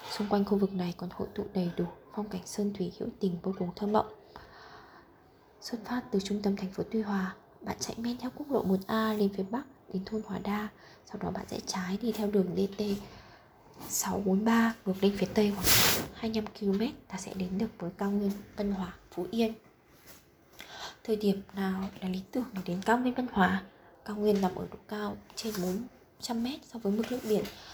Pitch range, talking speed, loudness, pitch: 190-220 Hz, 210 wpm, -32 LUFS, 205 Hz